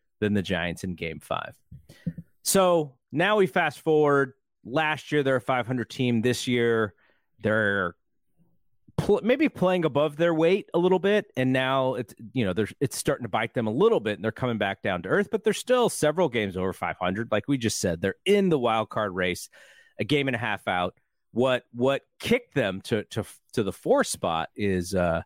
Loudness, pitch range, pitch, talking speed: -26 LUFS, 105-160 Hz, 130 Hz, 200 wpm